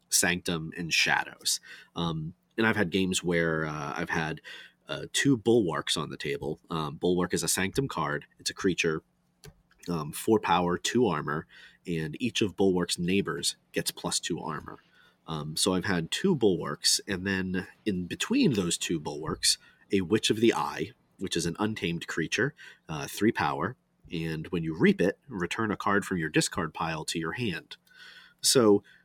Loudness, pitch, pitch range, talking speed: -28 LUFS, 90 Hz, 85-100 Hz, 170 wpm